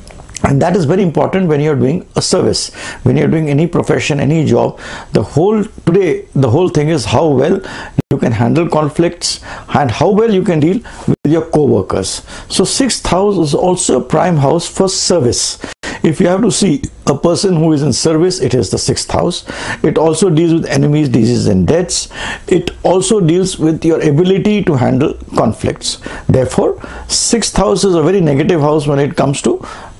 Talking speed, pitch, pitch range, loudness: 190 wpm, 160 Hz, 145-185 Hz, -12 LUFS